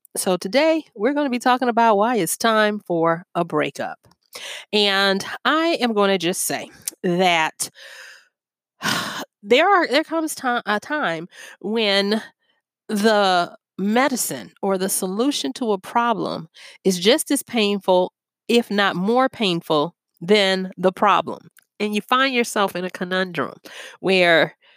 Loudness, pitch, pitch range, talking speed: -20 LUFS, 205 Hz, 185-245 Hz, 140 wpm